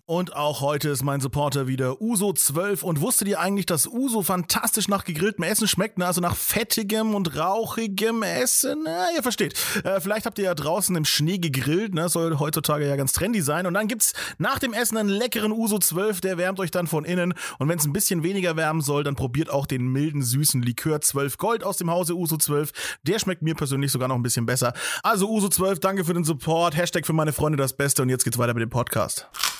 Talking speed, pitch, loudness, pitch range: 225 wpm, 175 Hz, -23 LUFS, 145-205 Hz